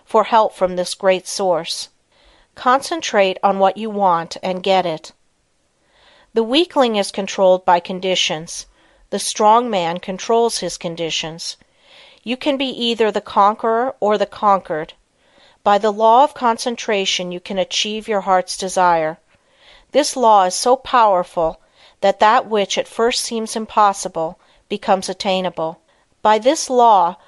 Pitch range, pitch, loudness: 185-230 Hz, 200 Hz, -17 LUFS